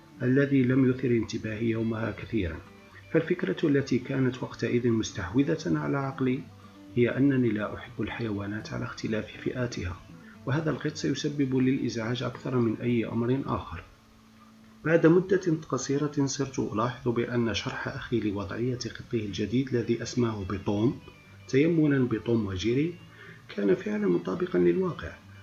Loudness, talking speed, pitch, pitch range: -28 LUFS, 120 wpm, 120 Hz, 110-140 Hz